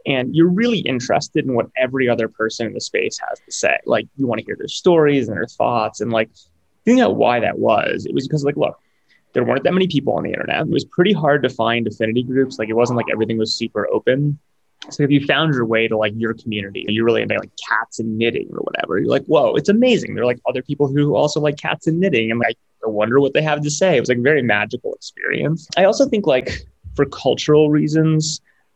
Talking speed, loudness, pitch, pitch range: 250 wpm, -18 LUFS, 135 Hz, 115-155 Hz